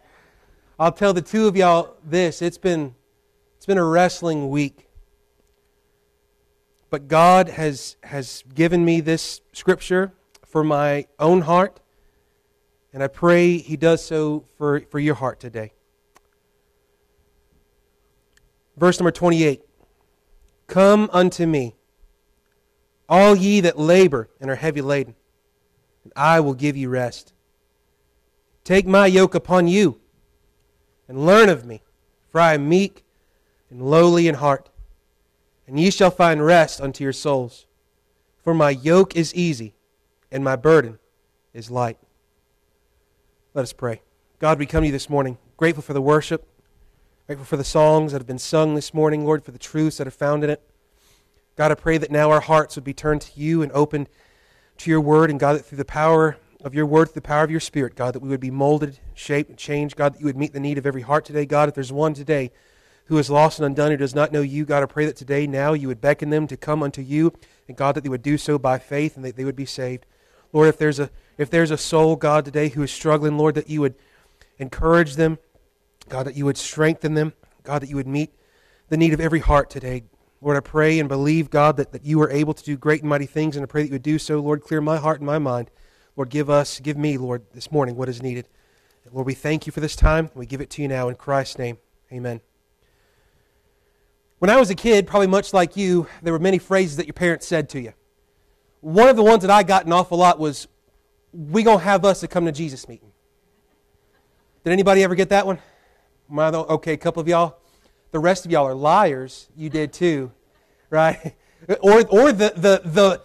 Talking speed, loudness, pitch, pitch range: 205 wpm, -19 LUFS, 150 Hz, 135-165 Hz